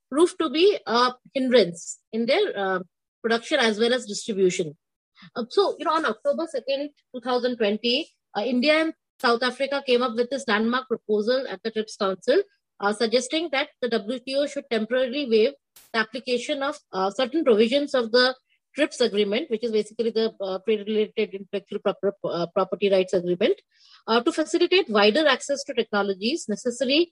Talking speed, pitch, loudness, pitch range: 160 wpm, 245 Hz, -24 LUFS, 210-280 Hz